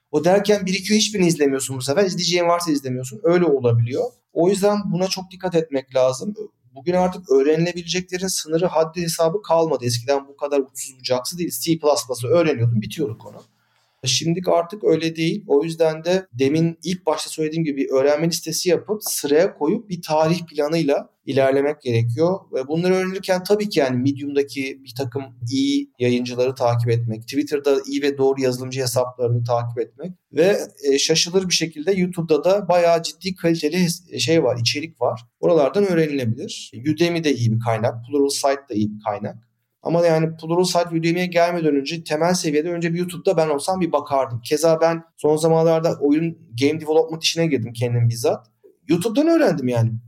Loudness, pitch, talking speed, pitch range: -20 LUFS, 155 Hz, 165 wpm, 135-175 Hz